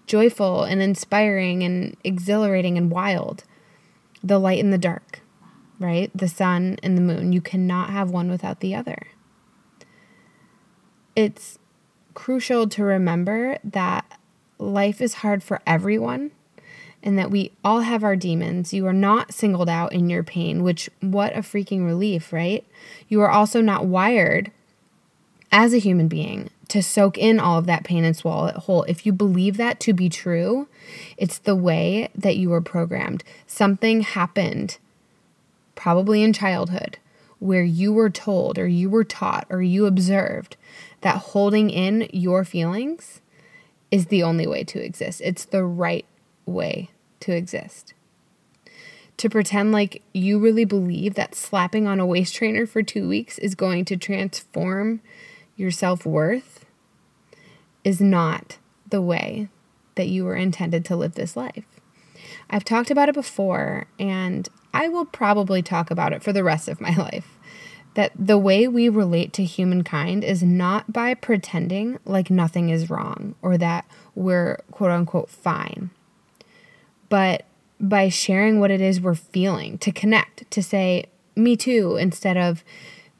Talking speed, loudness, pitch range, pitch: 155 wpm, -21 LUFS, 180-210 Hz, 195 Hz